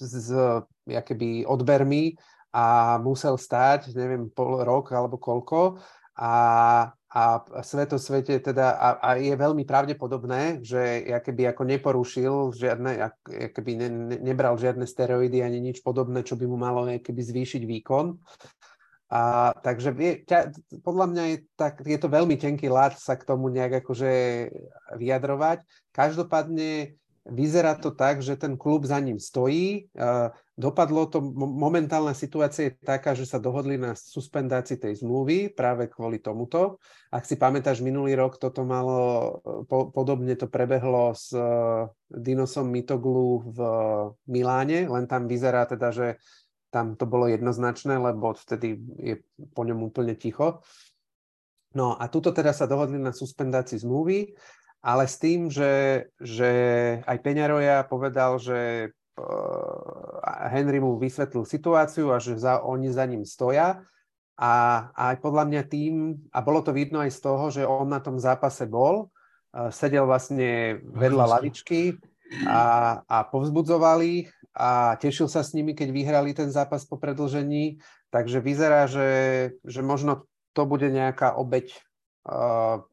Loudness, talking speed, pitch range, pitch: -25 LUFS, 140 wpm, 125-145 Hz, 130 Hz